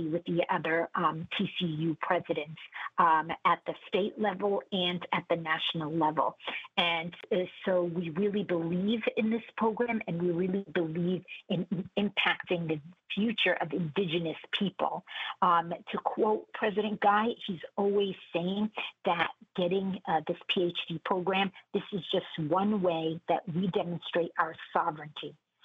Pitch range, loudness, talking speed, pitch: 170-200 Hz, -31 LUFS, 145 wpm, 180 Hz